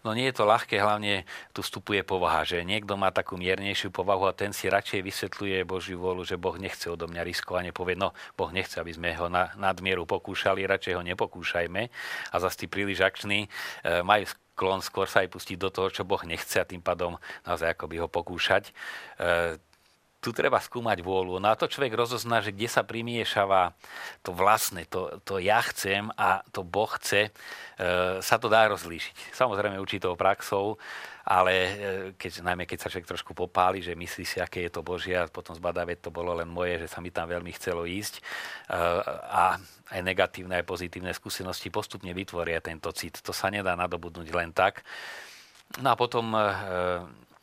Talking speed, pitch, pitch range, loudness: 185 wpm, 95 Hz, 85-100 Hz, -28 LUFS